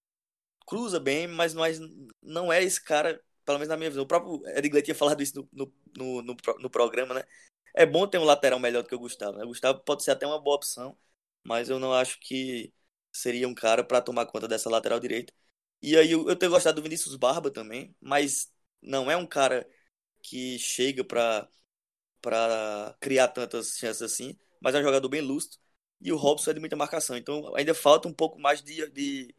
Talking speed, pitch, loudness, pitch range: 205 wpm, 140 Hz, -27 LUFS, 125-155 Hz